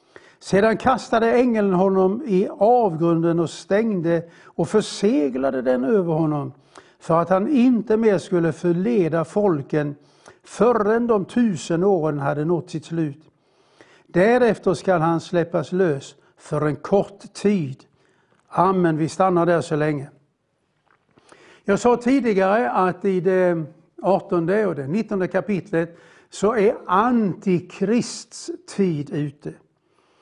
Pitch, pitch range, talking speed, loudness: 185 Hz, 160-210 Hz, 120 wpm, -20 LUFS